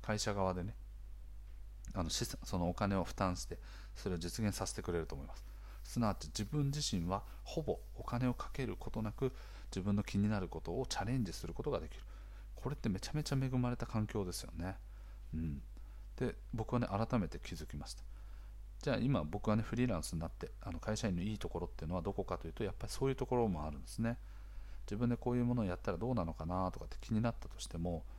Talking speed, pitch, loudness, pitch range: 435 characters per minute, 100 Hz, -40 LUFS, 90-115 Hz